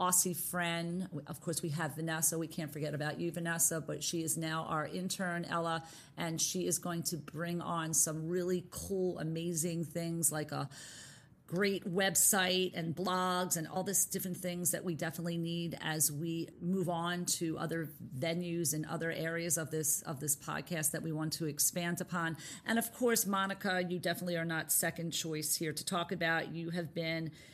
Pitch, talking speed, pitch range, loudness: 170 Hz, 185 wpm, 160-180 Hz, -35 LUFS